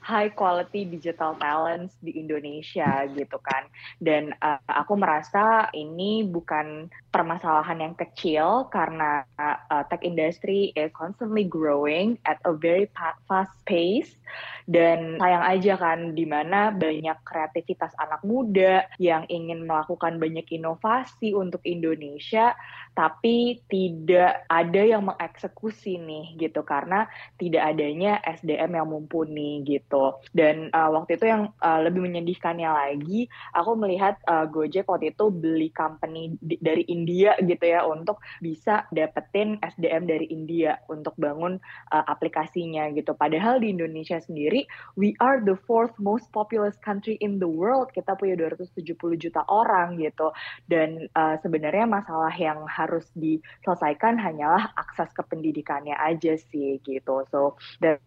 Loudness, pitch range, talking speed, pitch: -25 LUFS, 155-190 Hz, 135 wpm, 165 Hz